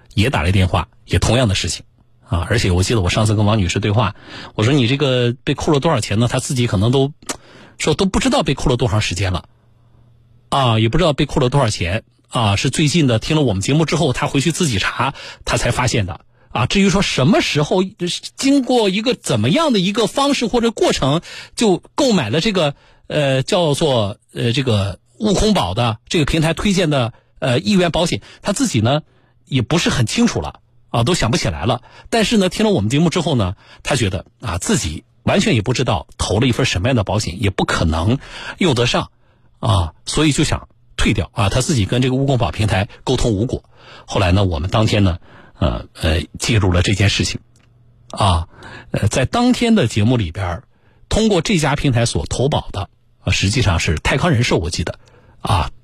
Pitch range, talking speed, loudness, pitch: 110-155 Hz, 295 characters per minute, -17 LUFS, 120 Hz